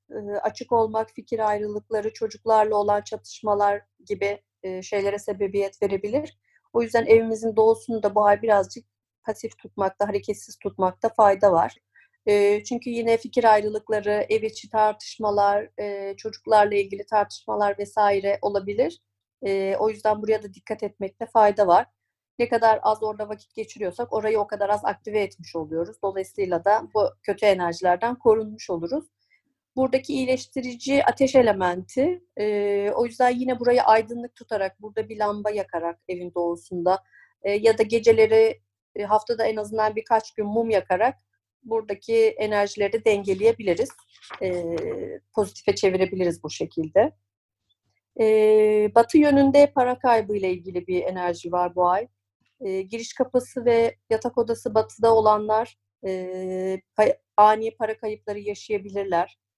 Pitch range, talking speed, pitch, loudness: 195-225 Hz, 130 wpm, 210 Hz, -23 LUFS